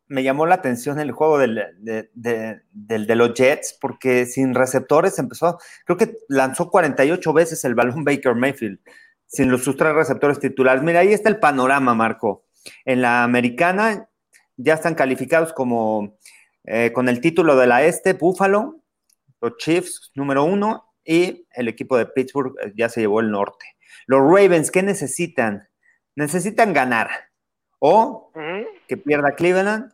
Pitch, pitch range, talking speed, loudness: 140 Hz, 125-180 Hz, 155 wpm, -19 LUFS